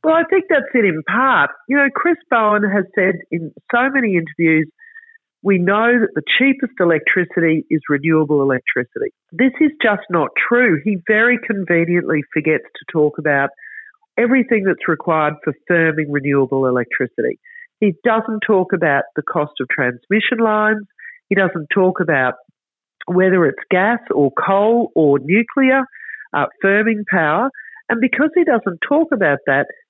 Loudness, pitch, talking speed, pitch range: -16 LUFS, 200 Hz, 150 wpm, 160-260 Hz